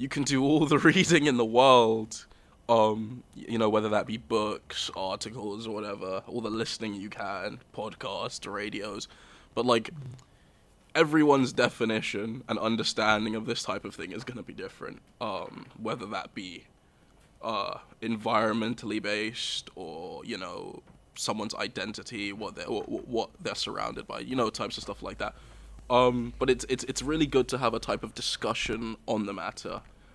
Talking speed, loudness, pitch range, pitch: 165 wpm, -29 LUFS, 110-130 Hz, 115 Hz